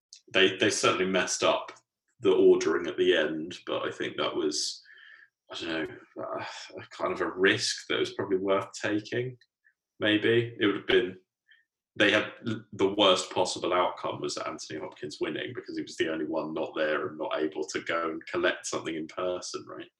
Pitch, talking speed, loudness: 365 Hz, 185 wpm, -28 LUFS